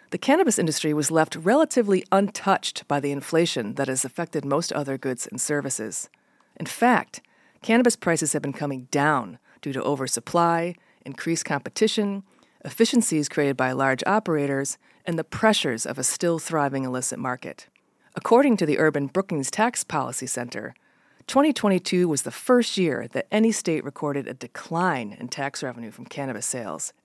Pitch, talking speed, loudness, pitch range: 155 Hz, 155 wpm, -24 LUFS, 140-195 Hz